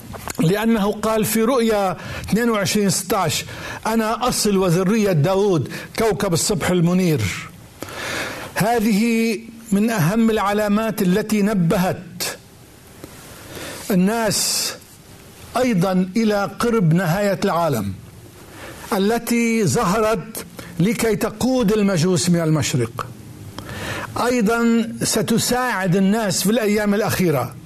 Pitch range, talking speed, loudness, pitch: 170-225 Hz, 80 wpm, -19 LUFS, 200 Hz